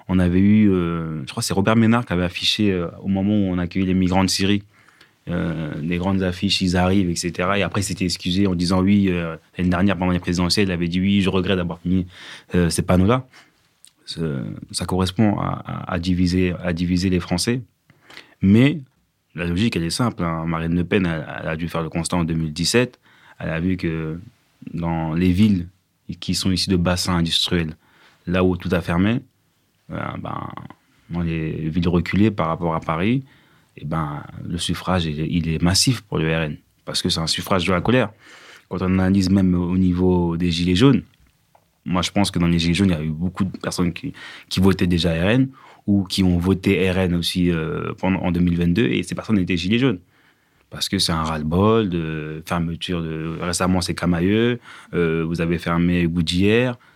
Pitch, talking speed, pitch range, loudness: 90 Hz, 200 wpm, 85-95 Hz, -20 LUFS